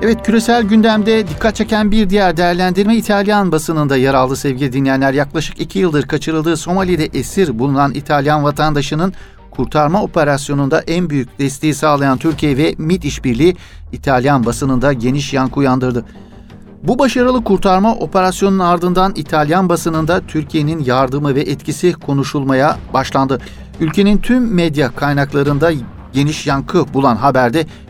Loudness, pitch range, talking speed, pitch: -14 LUFS, 140-185 Hz, 125 wpm, 155 Hz